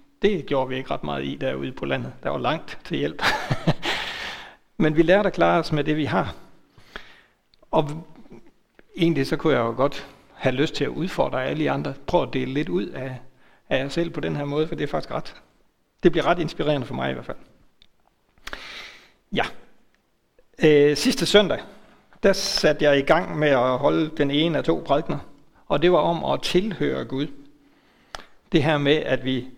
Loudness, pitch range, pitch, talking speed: -23 LUFS, 135-165 Hz, 150 Hz, 195 wpm